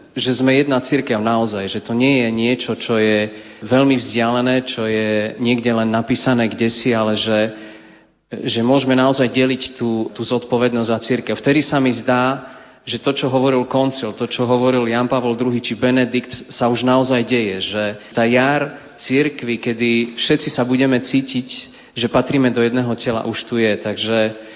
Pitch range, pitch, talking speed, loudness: 115-130 Hz, 120 Hz, 175 wpm, -17 LUFS